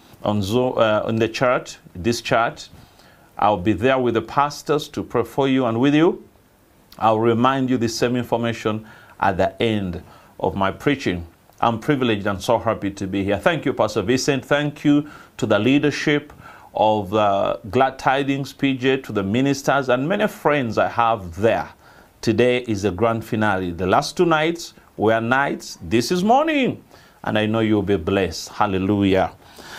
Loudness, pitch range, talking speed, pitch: -20 LUFS, 105-140 Hz, 175 wpm, 115 Hz